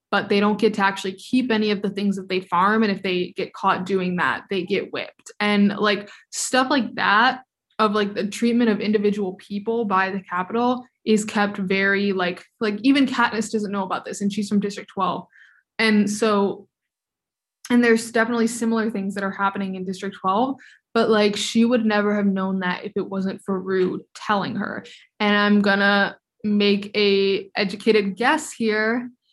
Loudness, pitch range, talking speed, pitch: -21 LUFS, 195-225 Hz, 185 wpm, 205 Hz